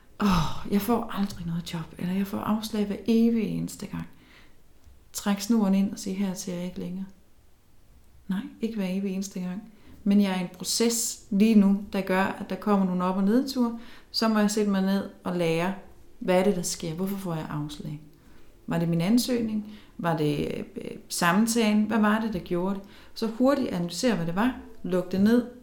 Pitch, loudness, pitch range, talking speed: 200 Hz, -26 LUFS, 180-225 Hz, 200 wpm